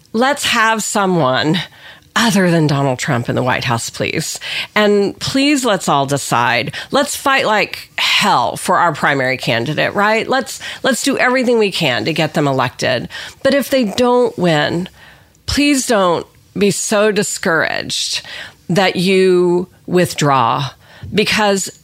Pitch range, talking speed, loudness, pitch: 145-220 Hz, 135 wpm, -15 LUFS, 185 Hz